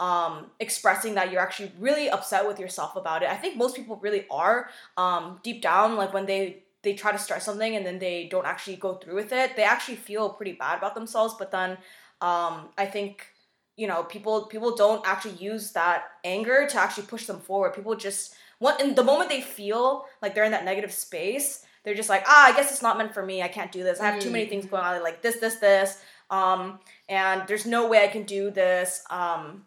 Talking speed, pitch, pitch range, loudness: 230 wpm, 200 Hz, 185-220 Hz, -25 LUFS